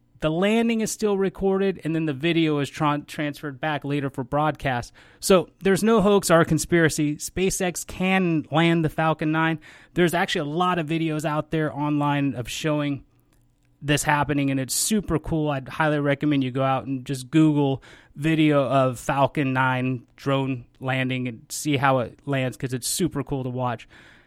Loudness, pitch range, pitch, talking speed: -23 LUFS, 135-165 Hz, 150 Hz, 175 wpm